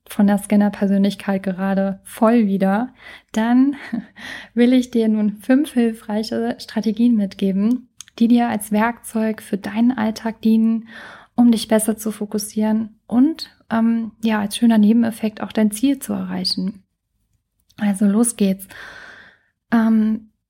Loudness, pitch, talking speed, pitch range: -19 LUFS, 220 Hz, 125 wpm, 210-235 Hz